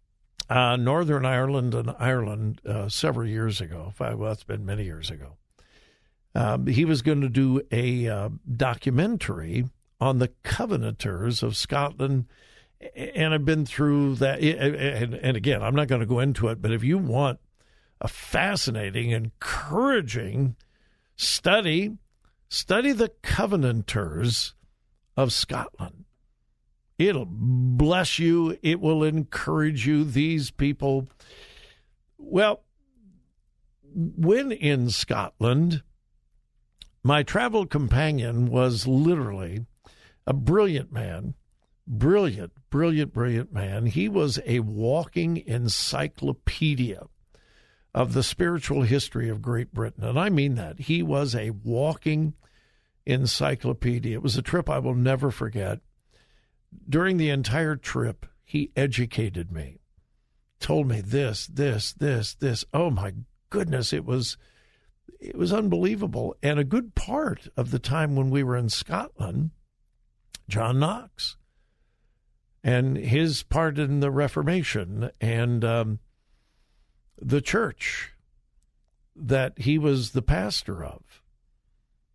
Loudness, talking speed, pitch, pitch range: -25 LUFS, 120 wpm, 130 Hz, 115-155 Hz